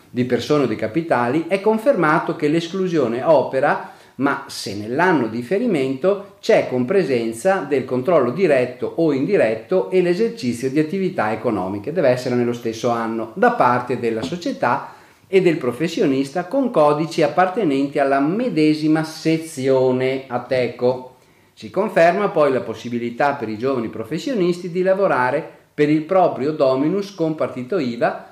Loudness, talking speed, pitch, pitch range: -19 LUFS, 140 wpm, 145 Hz, 125-180 Hz